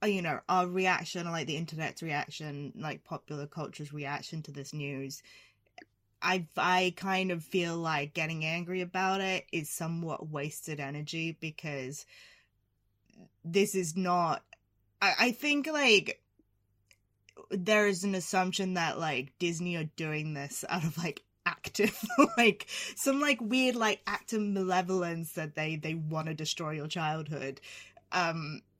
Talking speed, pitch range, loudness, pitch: 140 wpm, 150-185 Hz, -32 LUFS, 165 Hz